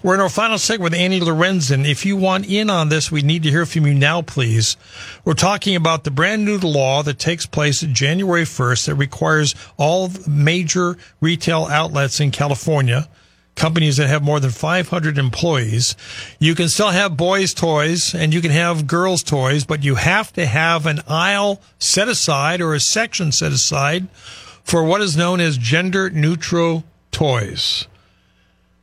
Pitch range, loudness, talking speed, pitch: 140-175 Hz, -17 LUFS, 175 wpm, 160 Hz